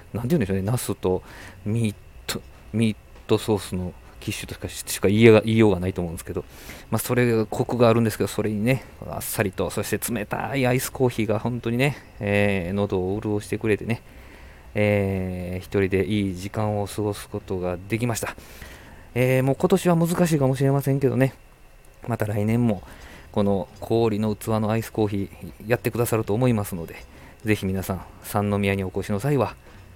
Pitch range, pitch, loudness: 95-115 Hz, 105 Hz, -24 LUFS